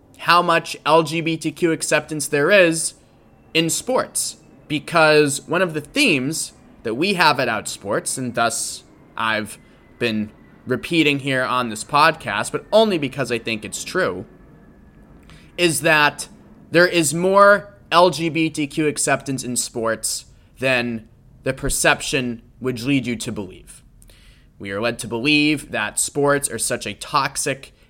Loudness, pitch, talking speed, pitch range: -19 LUFS, 140 Hz, 135 wpm, 120-160 Hz